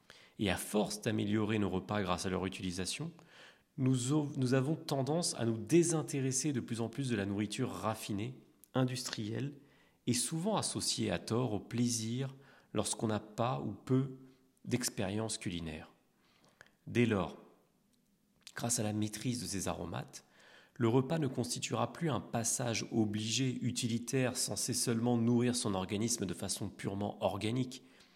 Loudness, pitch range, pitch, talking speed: -35 LUFS, 105-135 Hz, 120 Hz, 140 wpm